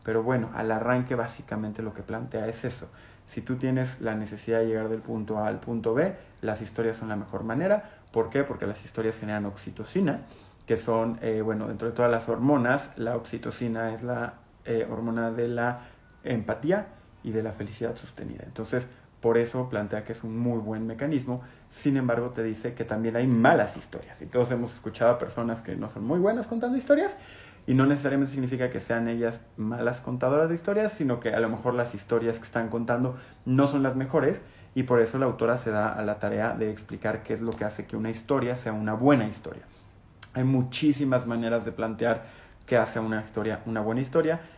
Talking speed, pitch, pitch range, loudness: 205 wpm, 115 Hz, 110-125 Hz, -28 LUFS